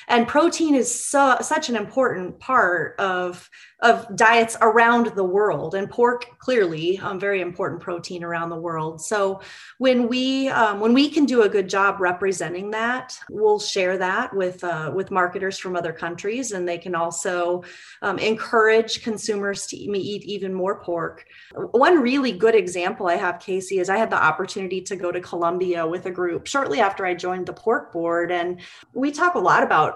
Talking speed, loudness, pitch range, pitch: 185 wpm, -21 LUFS, 180-235 Hz, 195 Hz